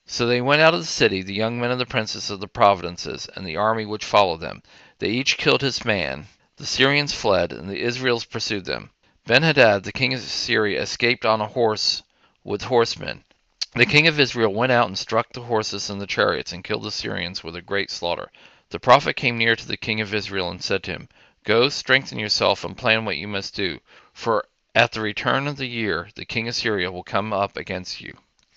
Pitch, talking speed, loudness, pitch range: 110 Hz, 220 wpm, -21 LUFS, 100-120 Hz